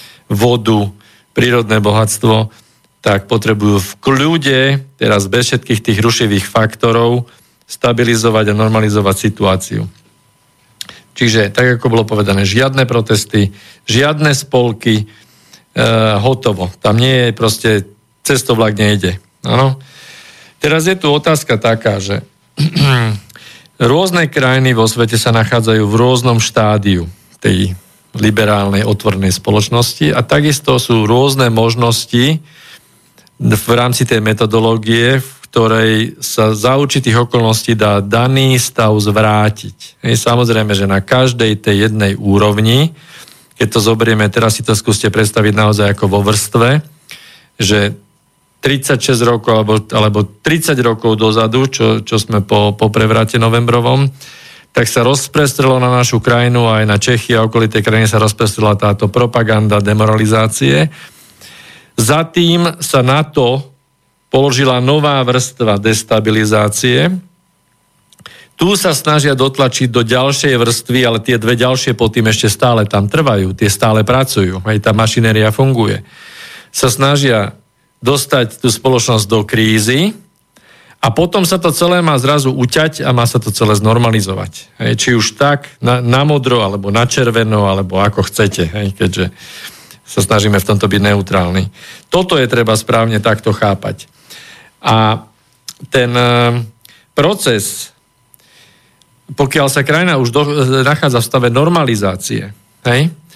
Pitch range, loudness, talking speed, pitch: 110-130 Hz, -12 LUFS, 125 wpm, 115 Hz